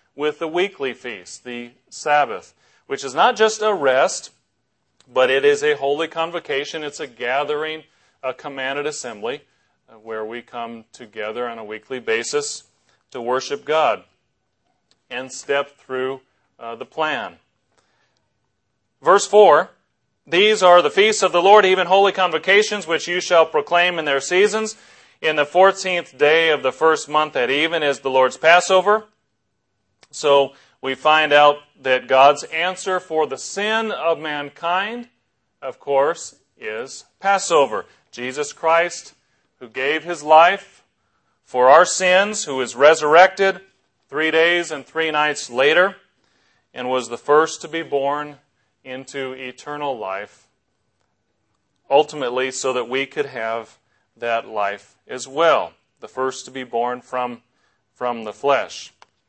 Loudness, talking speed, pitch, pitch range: -18 LUFS, 140 wpm, 150 Hz, 130-175 Hz